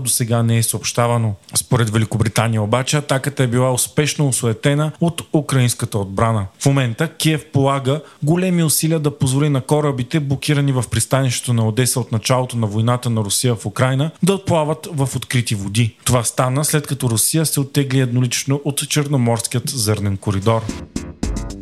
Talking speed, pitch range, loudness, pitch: 155 wpm, 115-145 Hz, -18 LUFS, 130 Hz